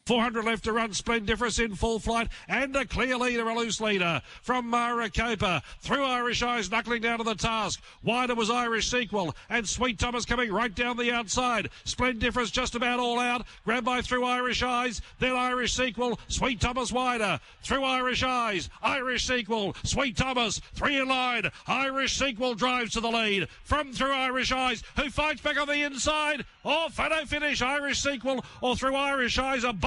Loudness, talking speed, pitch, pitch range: -27 LUFS, 180 wpm, 245 Hz, 230-255 Hz